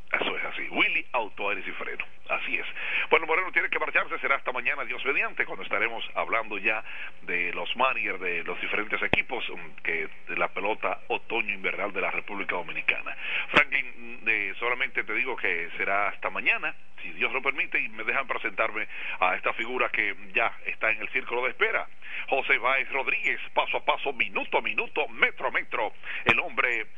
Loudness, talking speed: -27 LUFS, 185 wpm